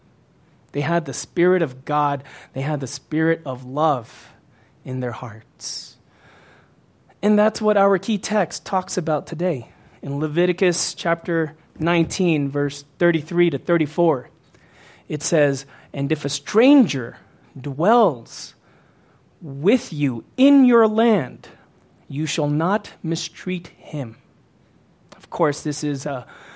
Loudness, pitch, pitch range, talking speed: -21 LUFS, 155 Hz, 140-180 Hz, 120 wpm